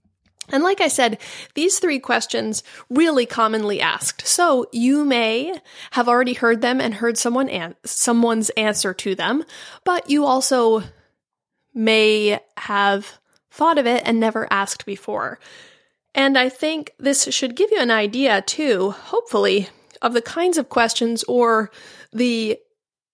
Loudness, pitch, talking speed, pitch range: -19 LUFS, 245 Hz, 145 wpm, 220-290 Hz